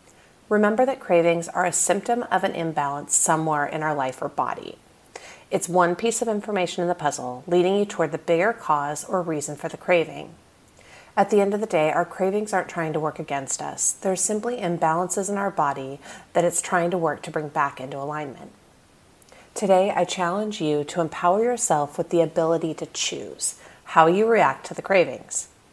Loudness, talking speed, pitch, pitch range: -23 LUFS, 190 wpm, 175 Hz, 155-195 Hz